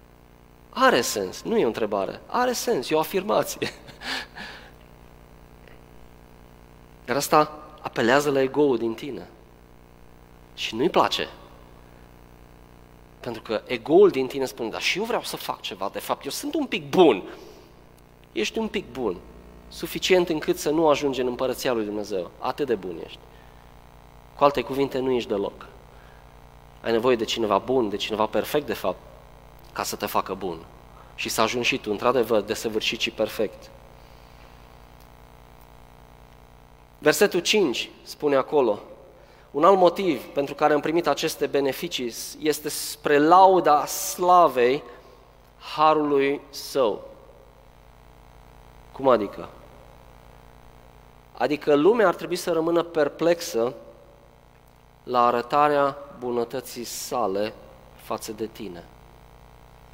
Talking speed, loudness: 125 wpm, -23 LUFS